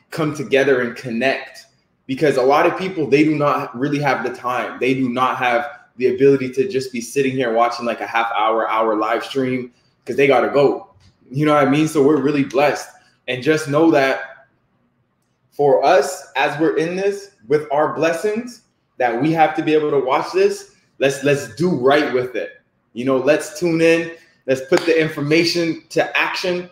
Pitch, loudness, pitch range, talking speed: 145 Hz, -18 LUFS, 130-160 Hz, 200 wpm